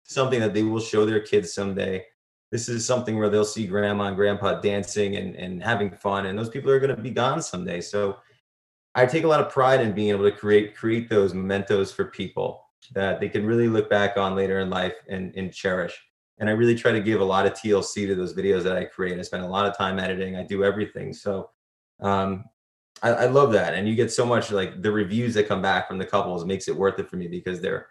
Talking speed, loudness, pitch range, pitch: 245 wpm, -24 LUFS, 95-115 Hz, 100 Hz